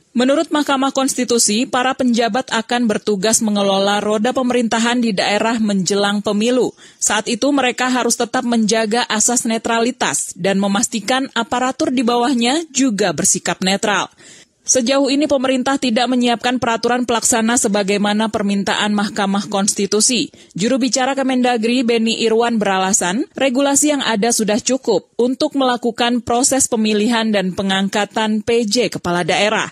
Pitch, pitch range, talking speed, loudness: 235 Hz, 210-255 Hz, 125 wpm, -16 LUFS